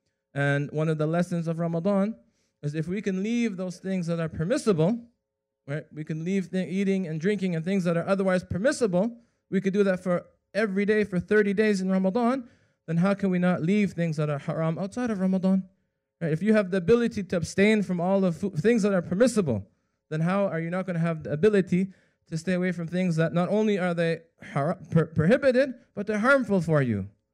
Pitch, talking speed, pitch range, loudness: 185 Hz, 220 wpm, 165-205 Hz, -26 LUFS